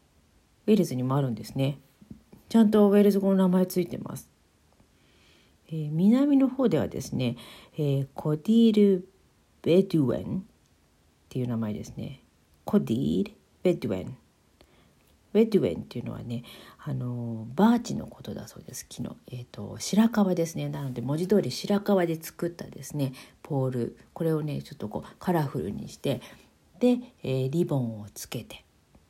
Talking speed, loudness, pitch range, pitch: 310 characters per minute, -27 LUFS, 125-200 Hz, 155 Hz